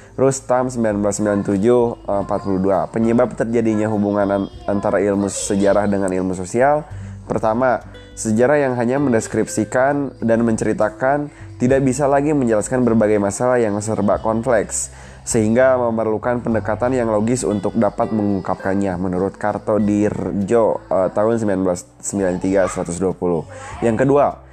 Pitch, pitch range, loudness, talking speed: 105 Hz, 100-120 Hz, -18 LUFS, 105 wpm